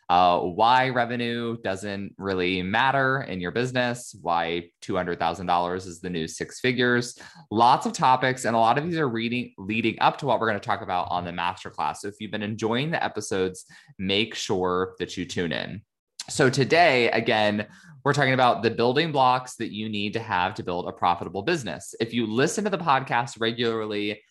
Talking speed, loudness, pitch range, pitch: 200 wpm, -24 LUFS, 95-125 Hz, 115 Hz